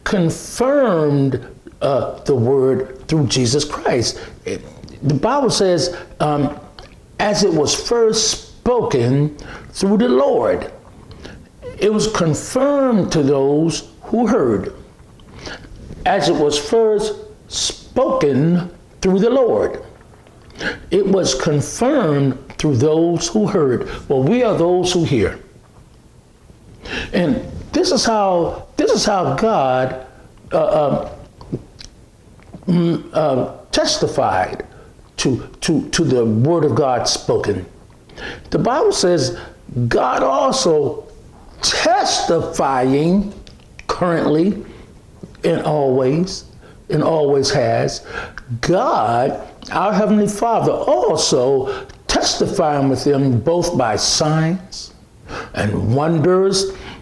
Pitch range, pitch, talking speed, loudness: 140-210 Hz, 165 Hz, 95 wpm, -17 LUFS